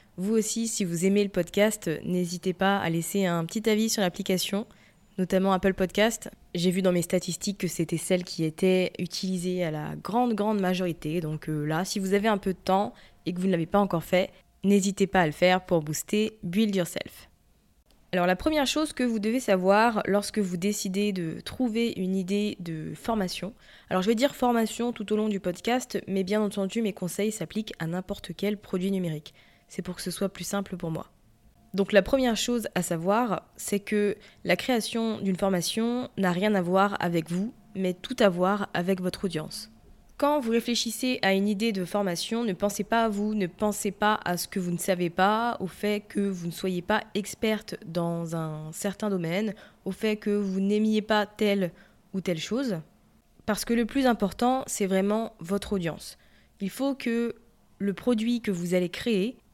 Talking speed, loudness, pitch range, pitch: 200 wpm, -27 LUFS, 180-215 Hz, 195 Hz